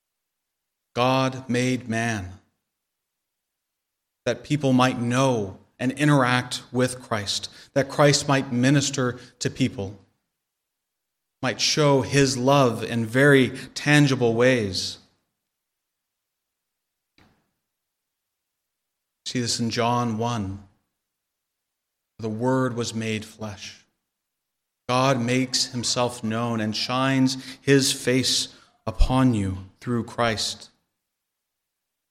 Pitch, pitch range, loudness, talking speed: 125 Hz, 115-130 Hz, -23 LUFS, 90 wpm